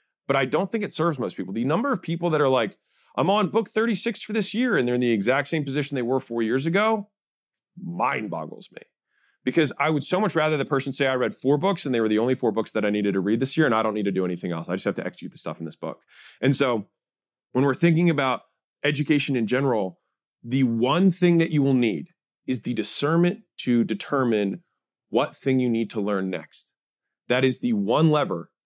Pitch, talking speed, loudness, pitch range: 135 Hz, 240 wpm, -24 LUFS, 115-170 Hz